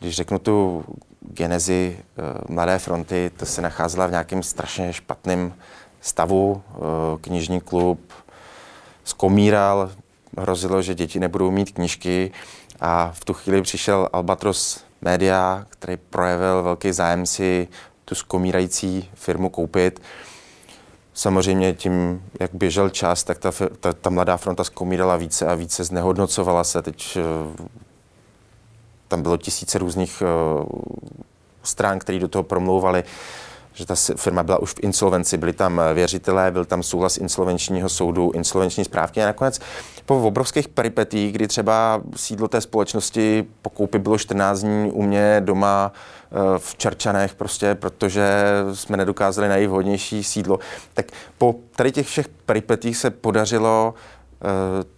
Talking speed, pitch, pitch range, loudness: 130 wpm, 95 Hz, 90-100 Hz, -21 LUFS